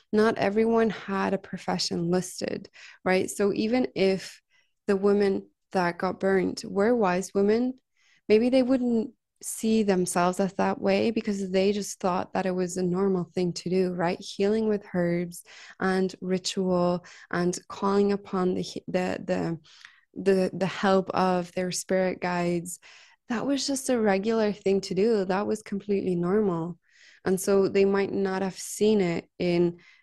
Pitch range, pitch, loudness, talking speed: 185-210 Hz, 195 Hz, -26 LUFS, 155 wpm